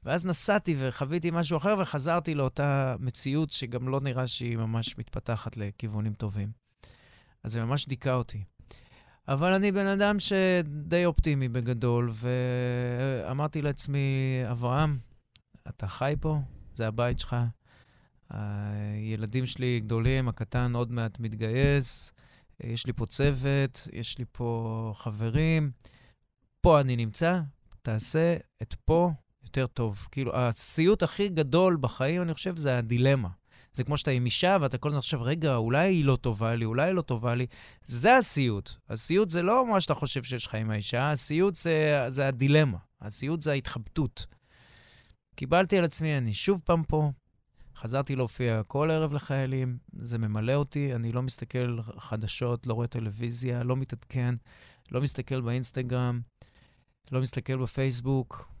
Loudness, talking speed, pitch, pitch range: -28 LUFS, 140 wpm, 130 Hz, 120-150 Hz